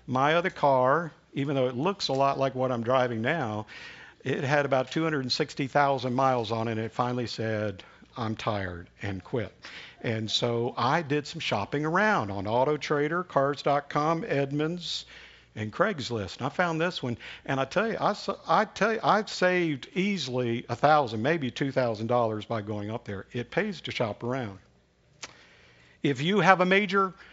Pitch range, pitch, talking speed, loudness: 115-160 Hz, 135 Hz, 170 wpm, -28 LUFS